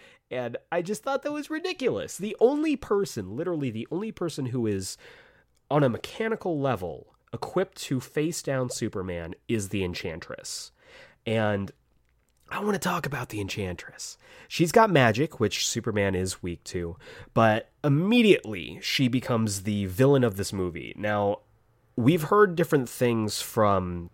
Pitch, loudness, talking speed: 125 Hz, -27 LUFS, 145 wpm